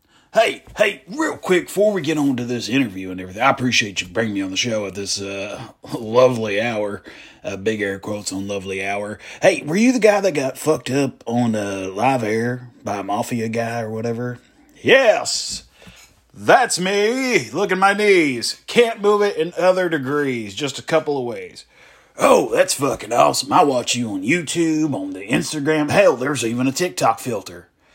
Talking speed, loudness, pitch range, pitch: 190 wpm, -19 LUFS, 110-180 Hz, 130 Hz